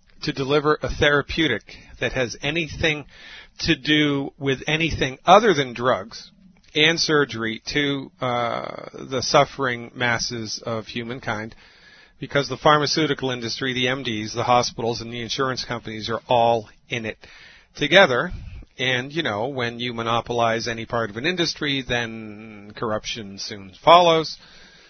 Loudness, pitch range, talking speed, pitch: -22 LUFS, 115-145 Hz, 135 wpm, 125 Hz